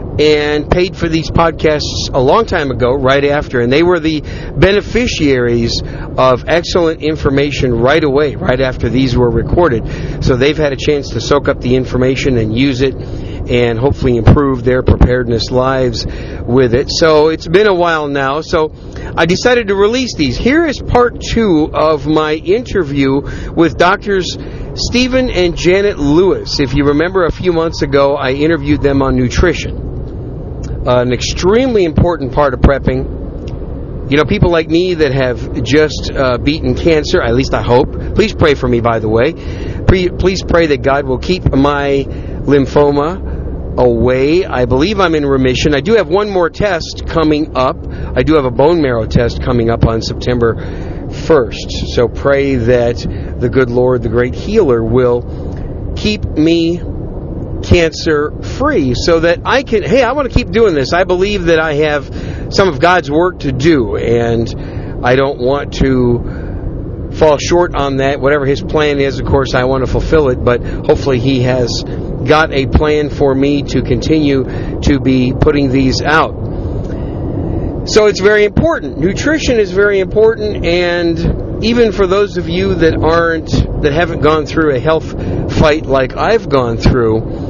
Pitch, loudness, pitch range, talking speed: 140 Hz, -12 LUFS, 120-160 Hz, 170 wpm